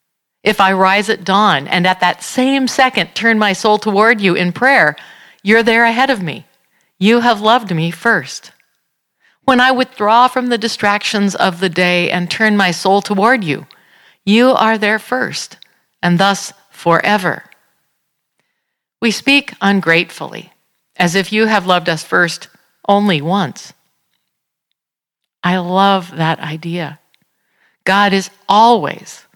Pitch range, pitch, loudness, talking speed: 180-230 Hz, 200 Hz, -13 LUFS, 140 wpm